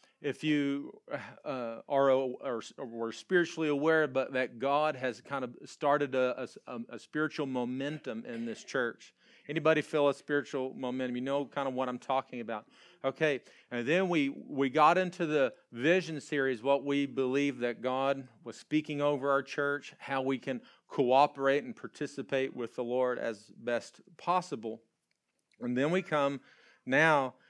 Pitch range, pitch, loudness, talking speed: 130-150 Hz, 140 Hz, -32 LUFS, 160 wpm